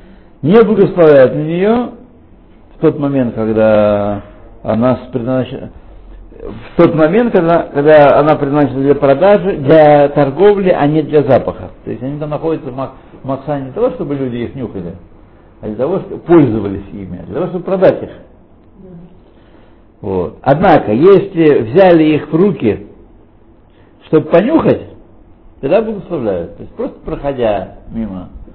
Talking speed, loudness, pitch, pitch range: 140 wpm, -11 LUFS, 140 Hz, 110-170 Hz